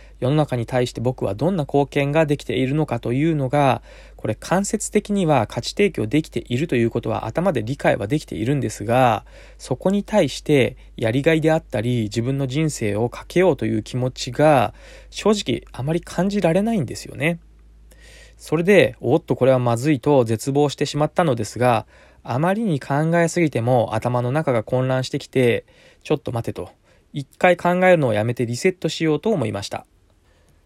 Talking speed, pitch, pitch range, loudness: 365 characters per minute, 135 Hz, 120-160 Hz, -20 LUFS